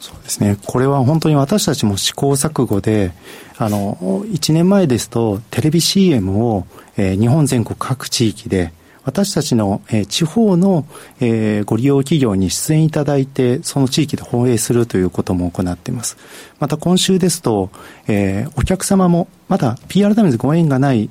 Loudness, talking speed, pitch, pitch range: -16 LUFS, 315 characters per minute, 130 Hz, 105-160 Hz